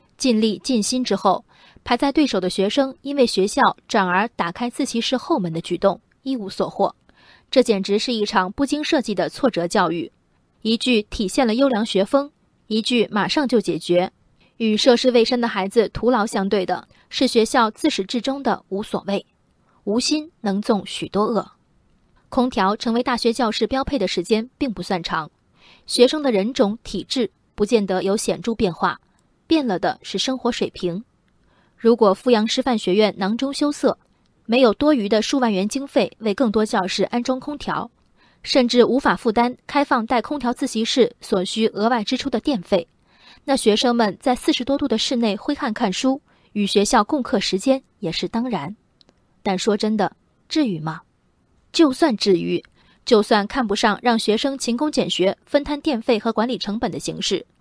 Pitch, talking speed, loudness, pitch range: 230 Hz, 260 characters per minute, -20 LUFS, 195-260 Hz